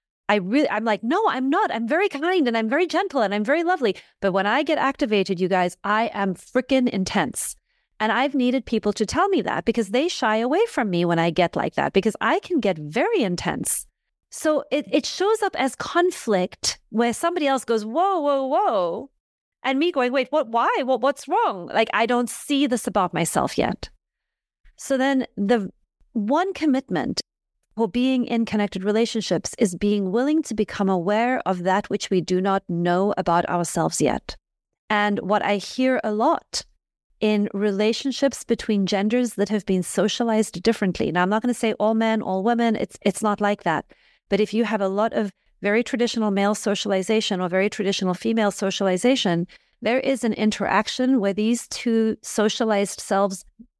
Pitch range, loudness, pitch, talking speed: 200-265 Hz, -22 LUFS, 220 Hz, 185 wpm